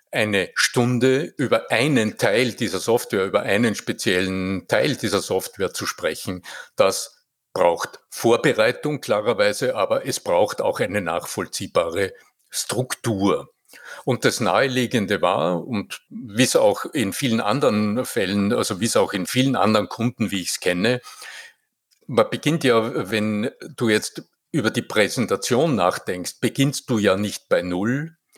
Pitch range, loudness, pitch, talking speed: 105-140 Hz, -21 LUFS, 120 Hz, 140 wpm